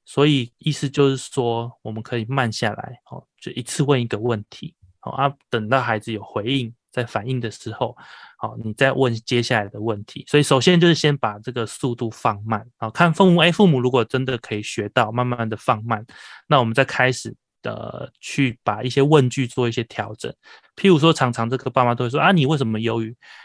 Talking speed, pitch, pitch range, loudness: 300 characters per minute, 125 Hz, 115-140 Hz, -20 LUFS